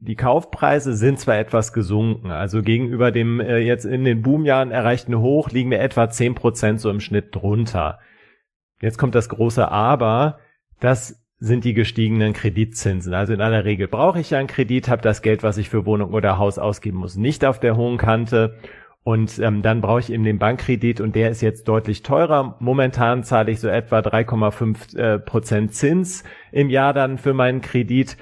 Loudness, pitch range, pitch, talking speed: -19 LUFS, 110-125 Hz, 115 Hz, 185 wpm